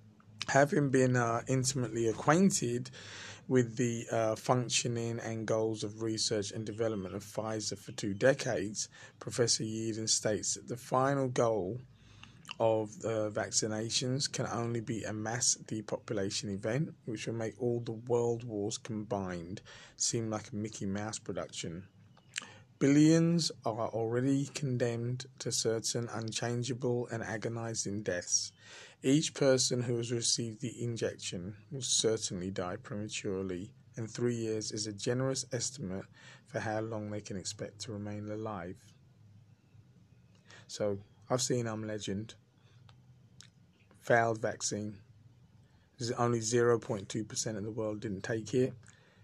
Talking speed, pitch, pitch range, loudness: 130 wpm, 115 Hz, 110-125 Hz, -33 LUFS